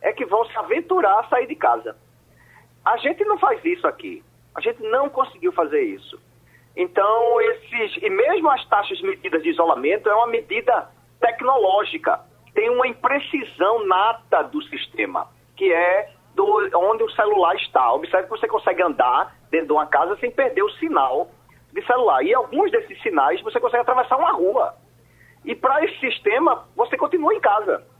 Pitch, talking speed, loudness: 345 Hz, 170 wpm, -20 LUFS